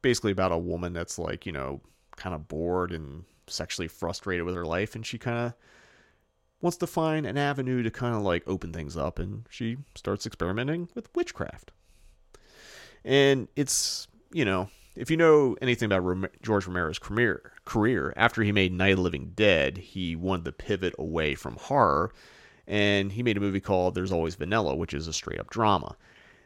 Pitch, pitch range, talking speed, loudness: 95 Hz, 85-120 Hz, 185 wpm, -28 LUFS